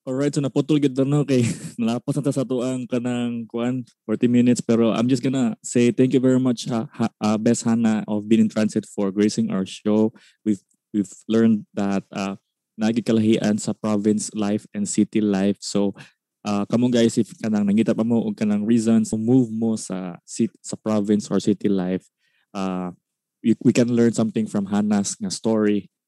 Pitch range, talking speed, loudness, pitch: 105-125 Hz, 175 wpm, -22 LUFS, 115 Hz